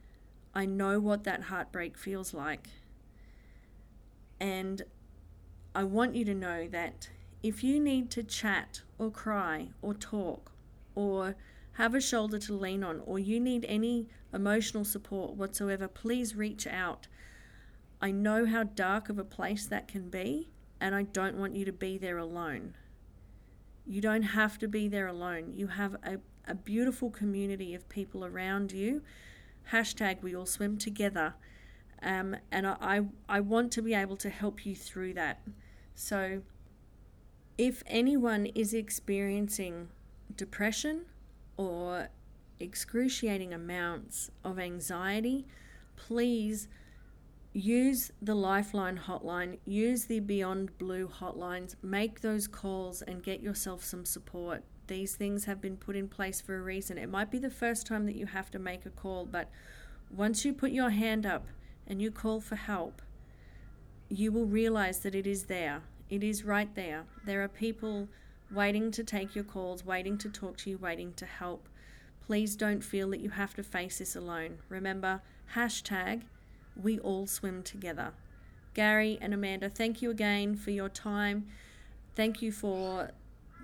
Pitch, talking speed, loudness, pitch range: 200 Hz, 155 wpm, -34 LUFS, 185-215 Hz